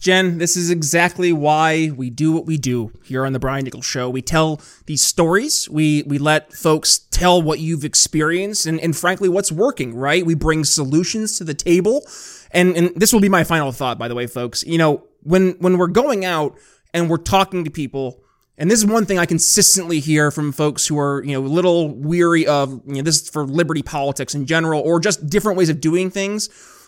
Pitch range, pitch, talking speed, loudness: 145-180 Hz, 160 Hz, 220 wpm, -17 LUFS